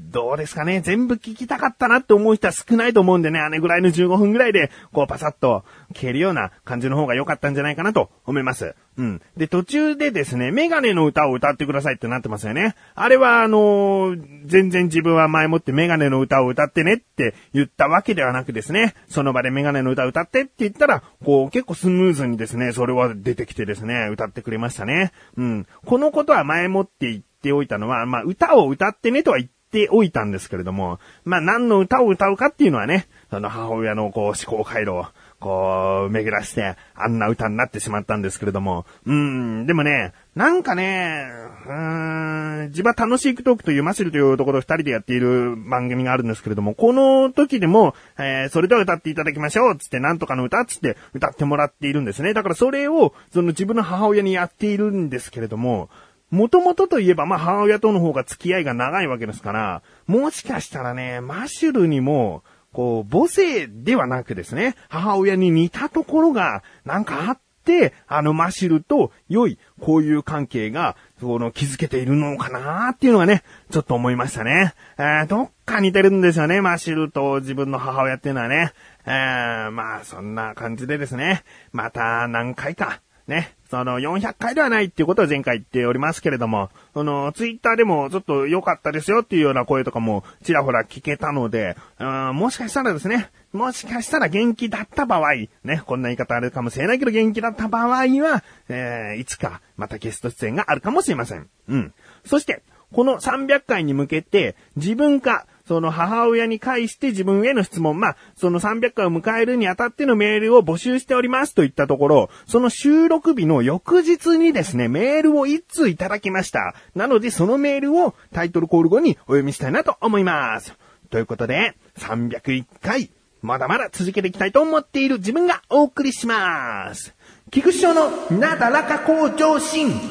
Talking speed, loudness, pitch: 405 characters per minute, -19 LUFS, 160 Hz